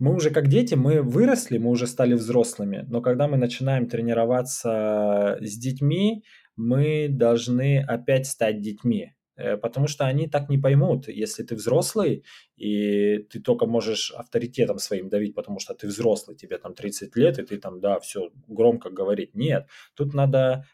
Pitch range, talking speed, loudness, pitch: 110-140 Hz, 160 wpm, -24 LUFS, 120 Hz